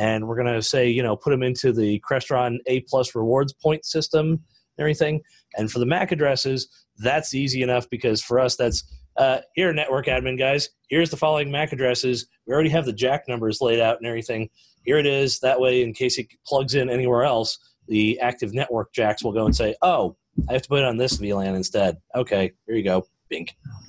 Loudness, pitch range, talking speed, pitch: -22 LUFS, 120-140 Hz, 215 wpm, 130 Hz